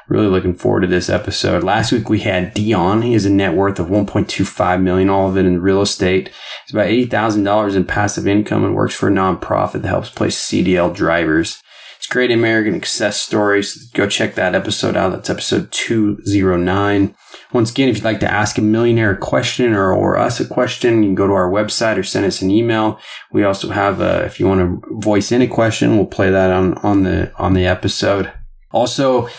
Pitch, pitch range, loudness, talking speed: 105 Hz, 95-115 Hz, -15 LUFS, 220 wpm